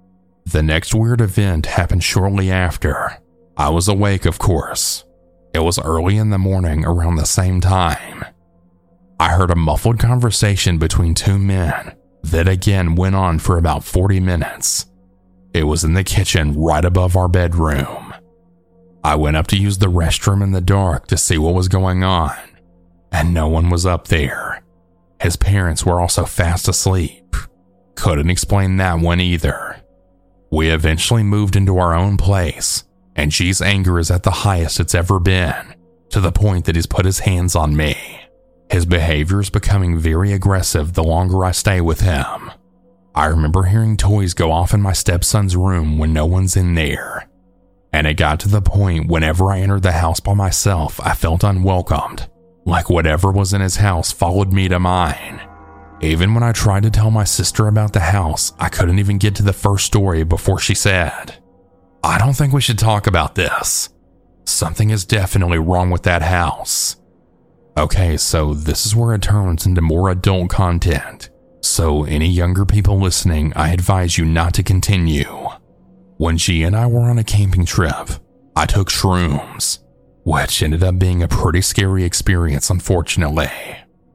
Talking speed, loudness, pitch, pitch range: 170 wpm, -16 LUFS, 90 Hz, 85-100 Hz